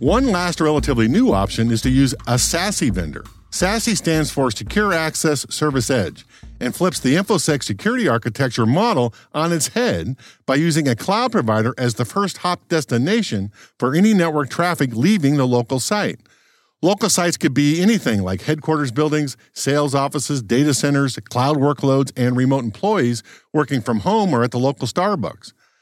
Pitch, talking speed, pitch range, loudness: 145 Hz, 165 wpm, 125-165 Hz, -18 LUFS